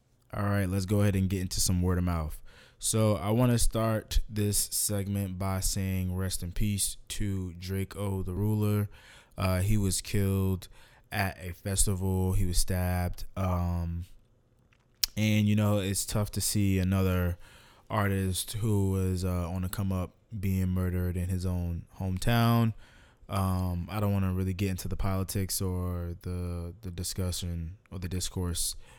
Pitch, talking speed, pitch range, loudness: 95 Hz, 160 wpm, 90-105 Hz, -30 LUFS